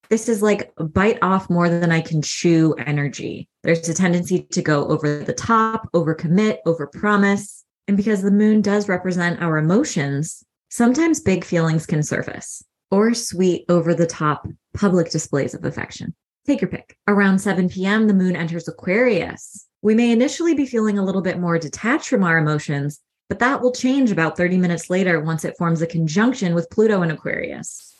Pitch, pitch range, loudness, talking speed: 180 Hz, 165-210 Hz, -19 LUFS, 185 wpm